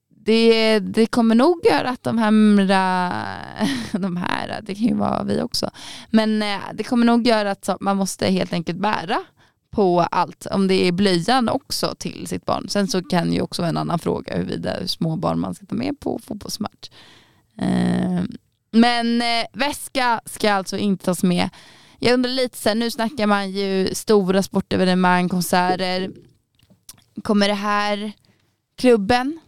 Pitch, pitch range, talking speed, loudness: 205 Hz, 185-230 Hz, 155 wpm, -20 LUFS